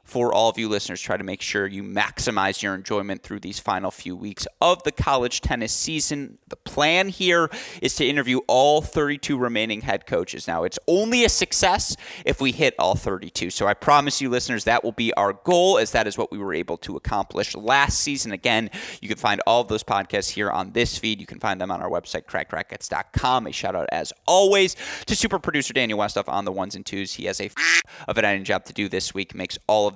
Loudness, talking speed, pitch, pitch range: -22 LUFS, 230 wpm, 120 Hz, 100-150 Hz